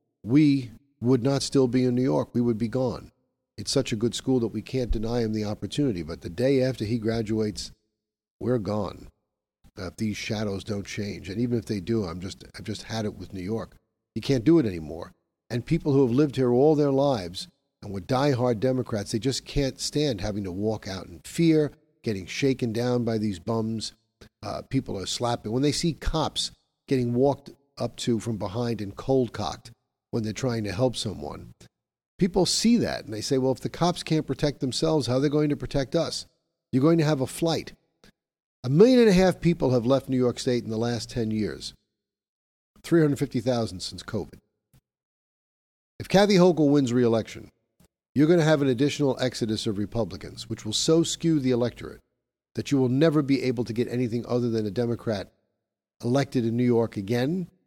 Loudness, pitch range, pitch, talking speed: -25 LUFS, 110-140 Hz, 120 Hz, 200 wpm